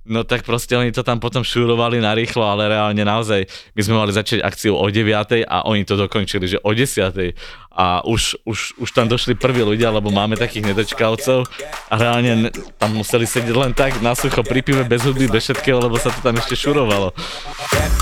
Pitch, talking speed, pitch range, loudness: 115 Hz, 195 wpm, 105-125 Hz, -17 LUFS